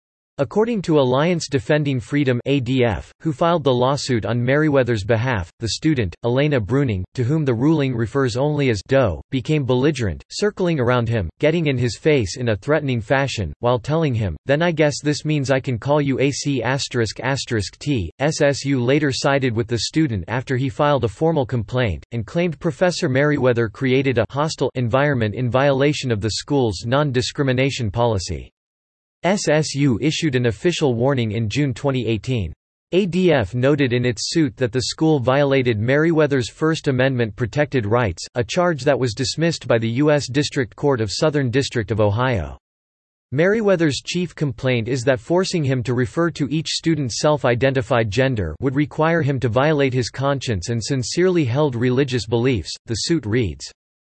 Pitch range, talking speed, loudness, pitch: 120-150 Hz, 160 wpm, -20 LUFS, 130 Hz